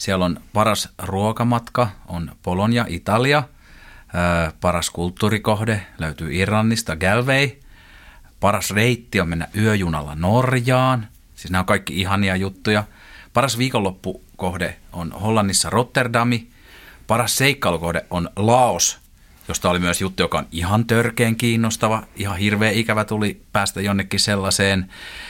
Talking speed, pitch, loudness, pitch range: 120 wpm, 100 Hz, -20 LUFS, 90-115 Hz